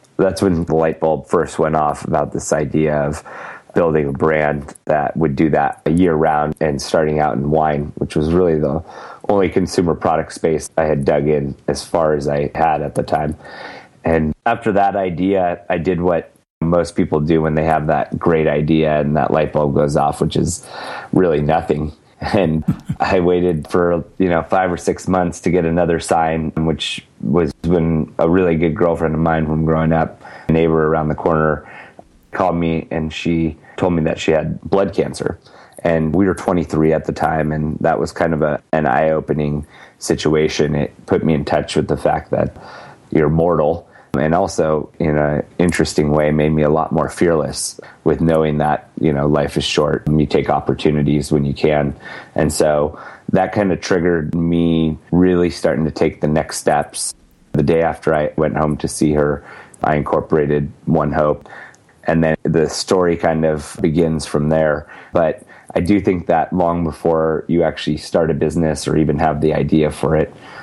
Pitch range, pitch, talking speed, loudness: 75-85 Hz, 80 Hz, 190 wpm, -17 LUFS